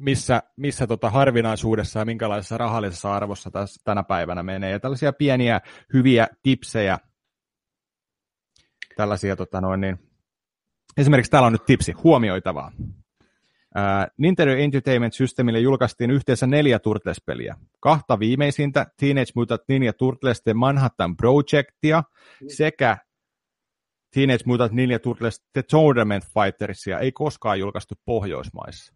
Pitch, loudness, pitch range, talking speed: 120 Hz, -21 LUFS, 105-135 Hz, 110 wpm